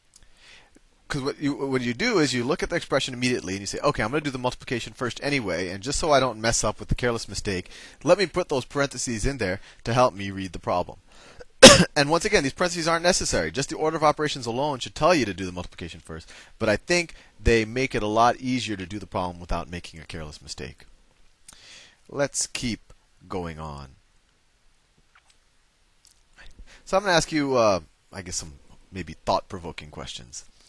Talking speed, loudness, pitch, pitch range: 205 wpm, -23 LUFS, 115 Hz, 90-140 Hz